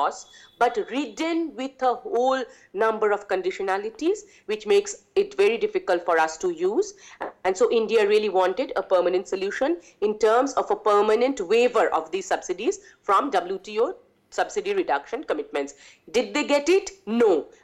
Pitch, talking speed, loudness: 315 Hz, 155 wpm, -24 LUFS